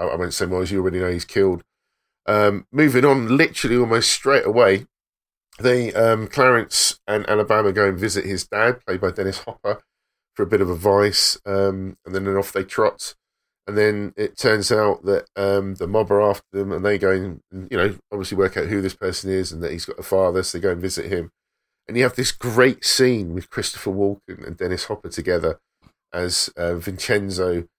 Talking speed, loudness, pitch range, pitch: 205 wpm, -20 LUFS, 95-105 Hz, 100 Hz